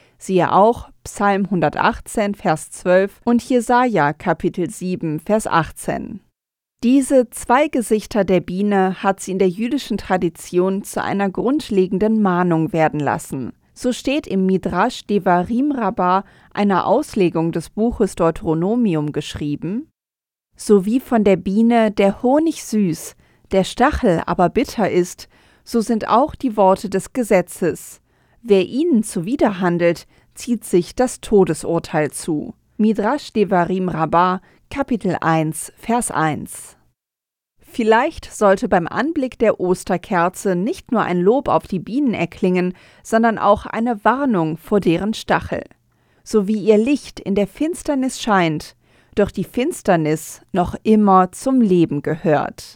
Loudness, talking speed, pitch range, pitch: -18 LUFS, 130 wpm, 175-230 Hz, 195 Hz